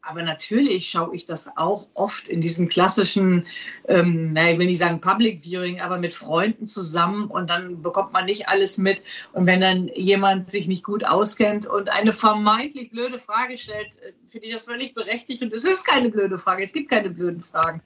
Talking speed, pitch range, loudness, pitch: 200 wpm, 180-220 Hz, -21 LUFS, 195 Hz